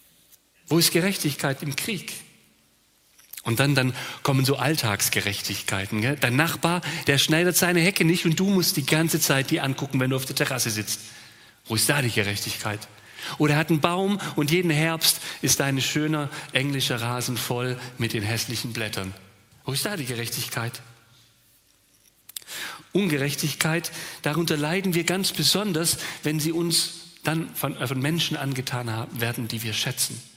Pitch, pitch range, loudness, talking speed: 140 Hz, 120-160 Hz, -24 LUFS, 155 wpm